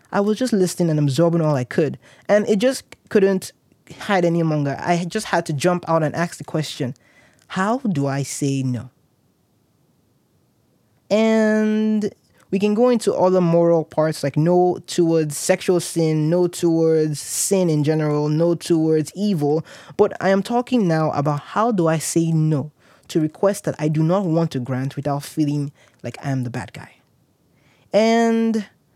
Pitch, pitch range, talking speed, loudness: 165 Hz, 145-195 Hz, 170 wpm, -20 LUFS